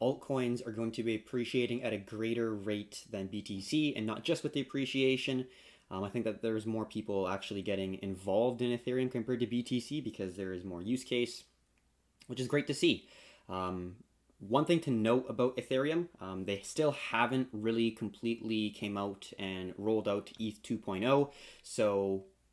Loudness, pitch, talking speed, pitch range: -35 LUFS, 115 Hz, 175 wpm, 100-125 Hz